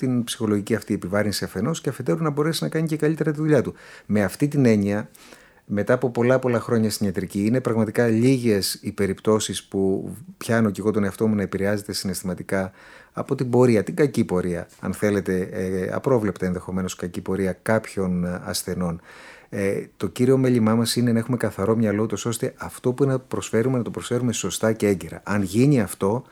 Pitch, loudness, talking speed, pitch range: 110 Hz, -23 LUFS, 190 wpm, 95-125 Hz